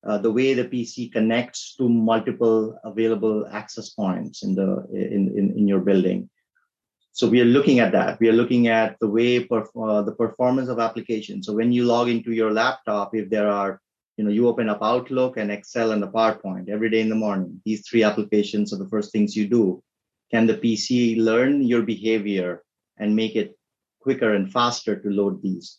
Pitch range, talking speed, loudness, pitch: 105-120 Hz, 200 wpm, -22 LUFS, 110 Hz